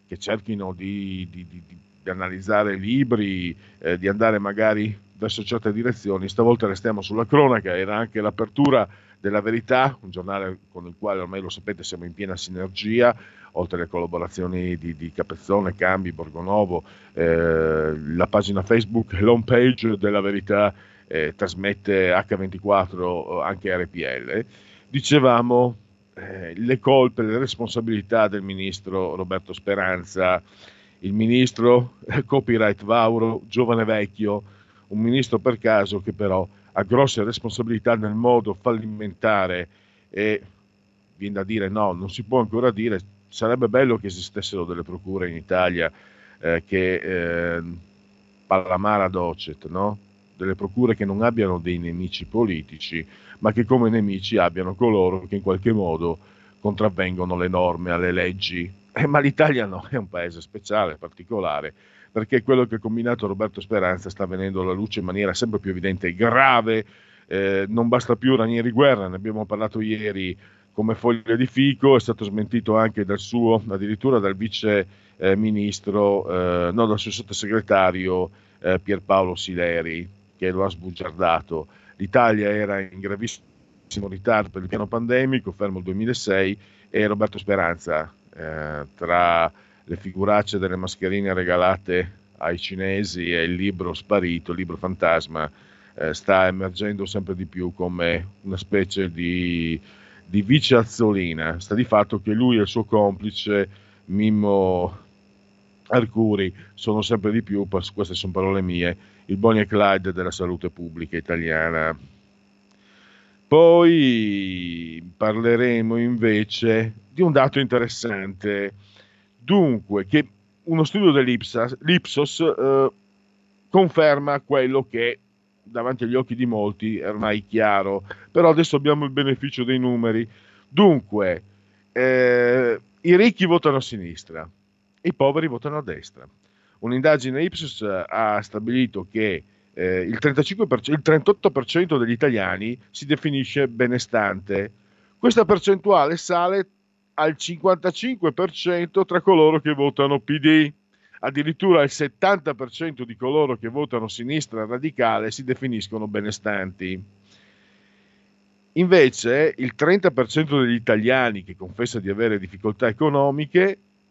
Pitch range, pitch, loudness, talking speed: 95-120 Hz, 105 Hz, -22 LUFS, 130 wpm